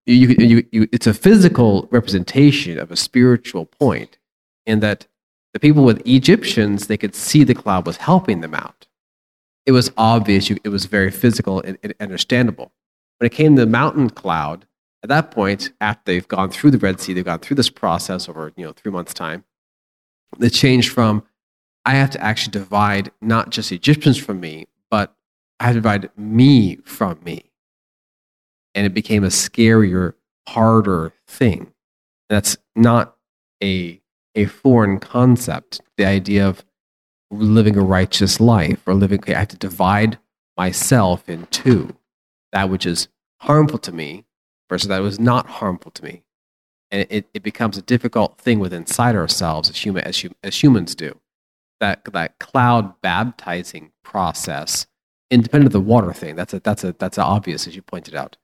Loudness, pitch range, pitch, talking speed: -17 LUFS, 95-120 Hz, 105 Hz, 170 wpm